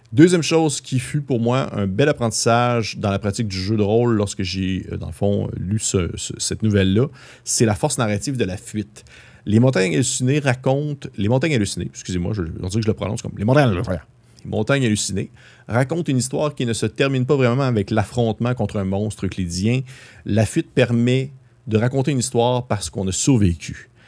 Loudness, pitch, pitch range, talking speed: -20 LUFS, 115 Hz, 100-130 Hz, 195 wpm